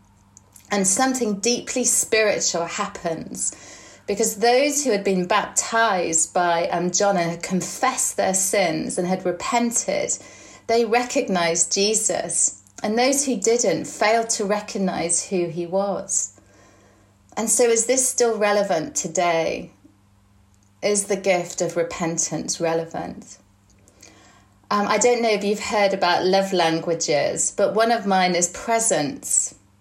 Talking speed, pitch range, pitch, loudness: 130 wpm, 165-220 Hz, 185 Hz, -21 LUFS